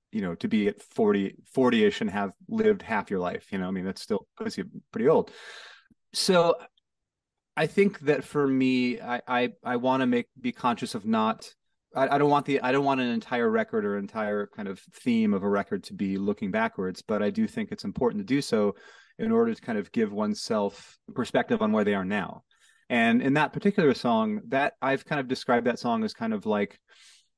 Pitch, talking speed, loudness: 175 Hz, 220 wpm, -27 LUFS